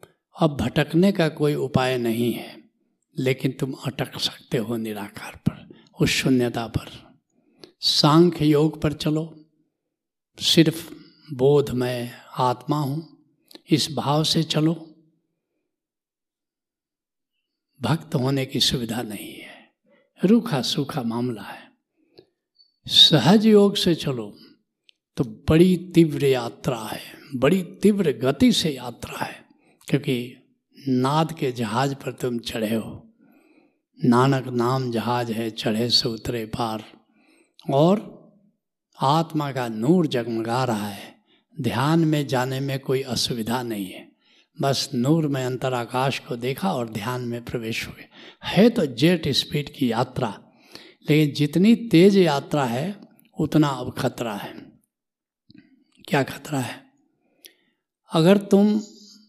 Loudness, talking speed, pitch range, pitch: -22 LUFS, 120 wpm, 125-175 Hz, 145 Hz